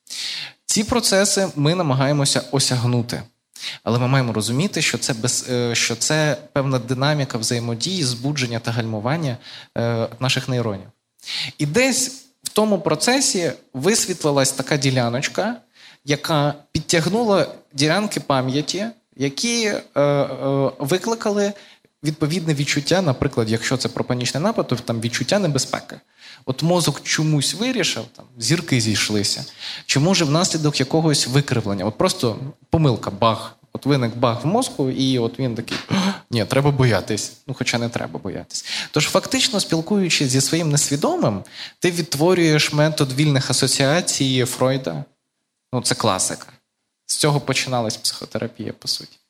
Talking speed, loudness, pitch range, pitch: 125 wpm, -20 LUFS, 125-165 Hz, 140 Hz